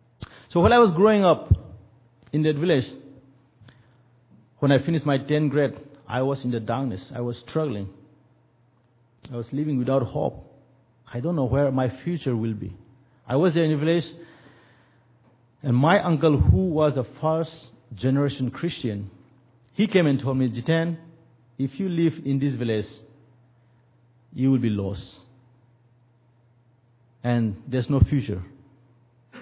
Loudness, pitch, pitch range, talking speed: -23 LUFS, 130 Hz, 120-145 Hz, 145 wpm